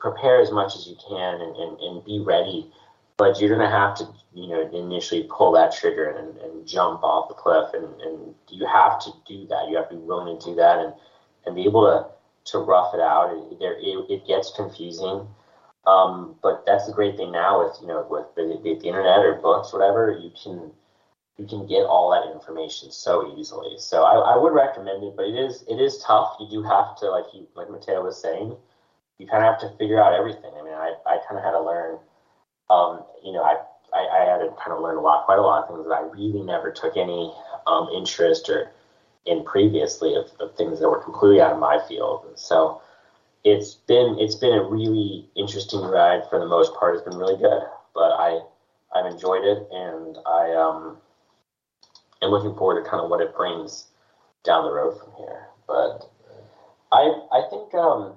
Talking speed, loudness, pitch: 215 wpm, -21 LUFS, 110 Hz